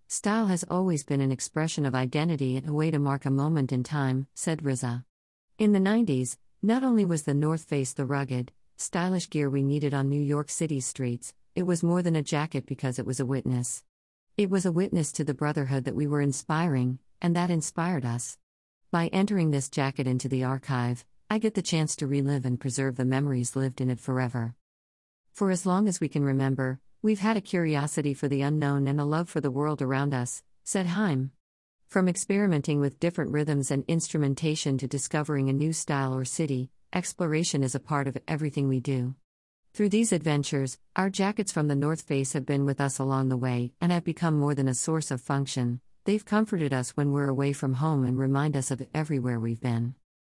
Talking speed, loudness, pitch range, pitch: 205 wpm, -28 LUFS, 130-165 Hz, 140 Hz